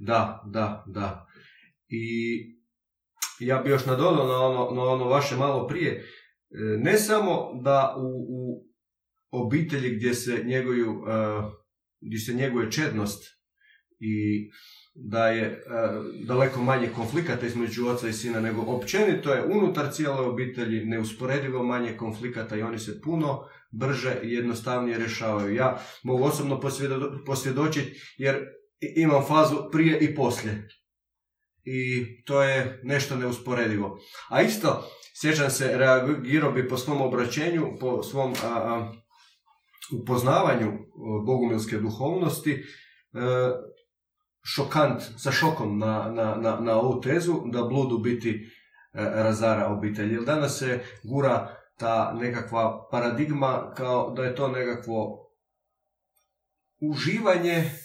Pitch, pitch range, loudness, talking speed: 125 Hz, 115-140 Hz, -26 LUFS, 120 wpm